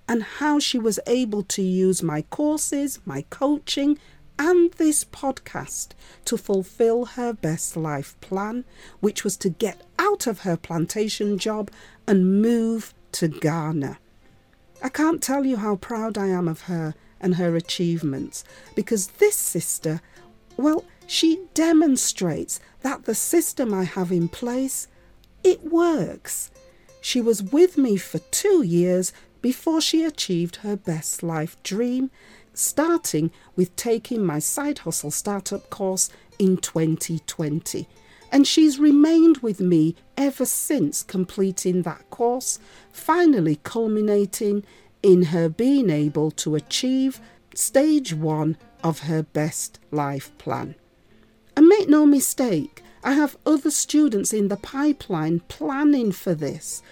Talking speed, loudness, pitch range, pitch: 130 wpm, -22 LUFS, 170-275 Hz, 205 Hz